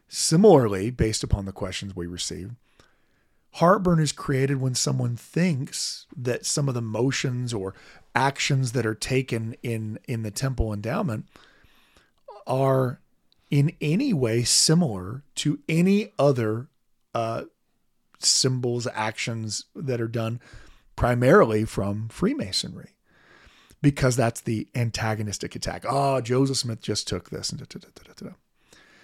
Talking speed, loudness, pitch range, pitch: 130 wpm, -24 LUFS, 110-140 Hz, 125 Hz